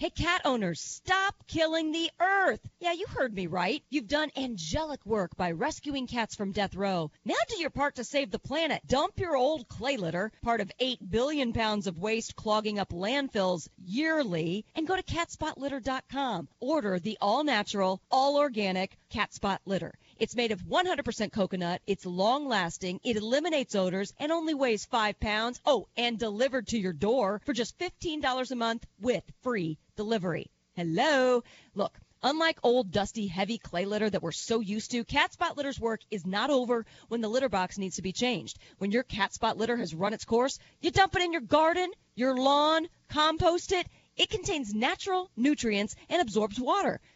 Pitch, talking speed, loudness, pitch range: 235 Hz, 180 wpm, -30 LUFS, 200-290 Hz